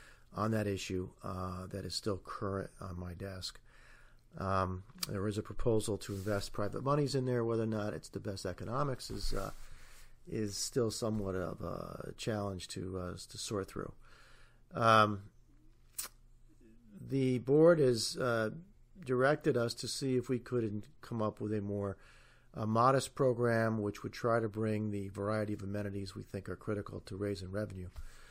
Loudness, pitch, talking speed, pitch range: -35 LUFS, 105 Hz, 165 wpm, 95-120 Hz